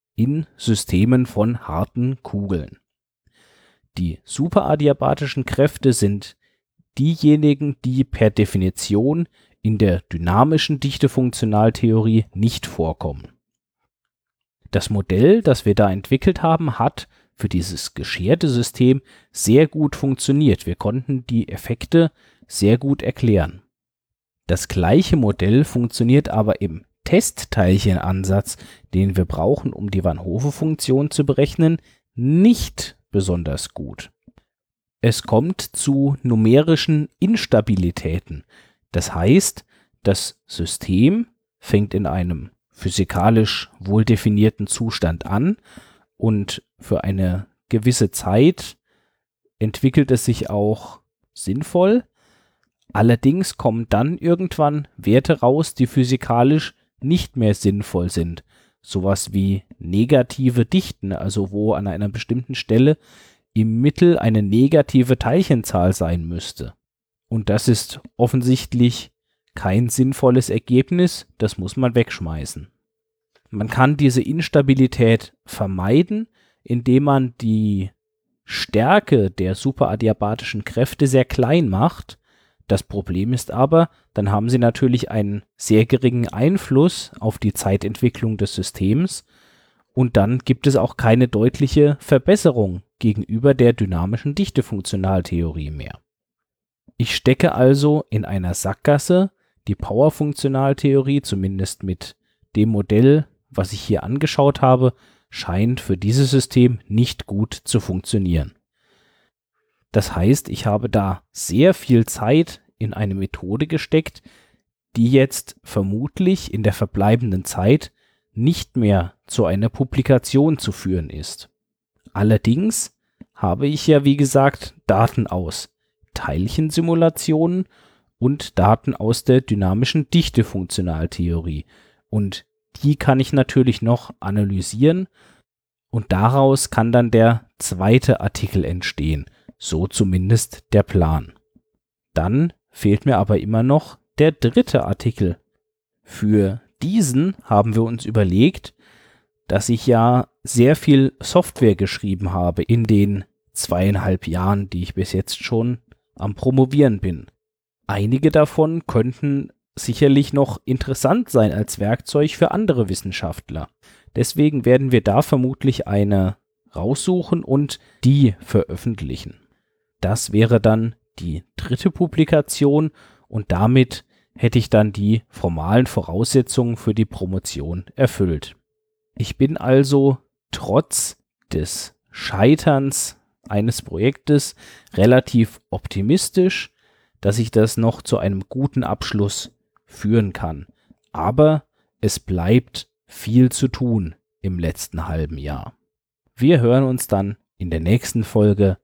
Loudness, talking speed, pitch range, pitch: -19 LUFS, 110 wpm, 100-135 Hz, 115 Hz